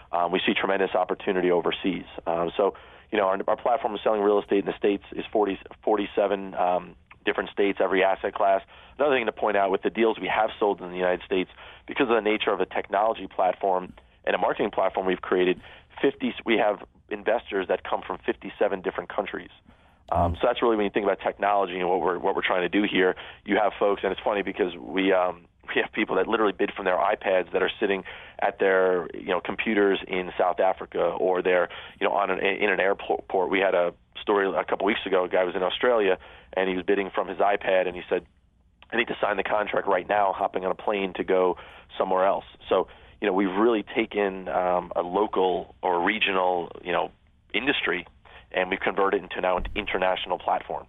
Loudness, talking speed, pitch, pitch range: -25 LUFS, 220 wpm, 95 Hz, 90-100 Hz